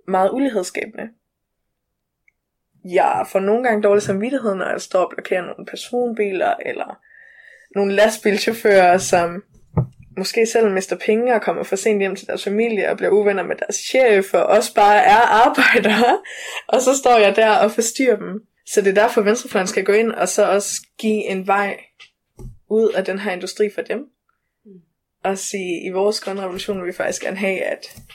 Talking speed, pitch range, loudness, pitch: 180 wpm, 195-230 Hz, -18 LUFS, 210 Hz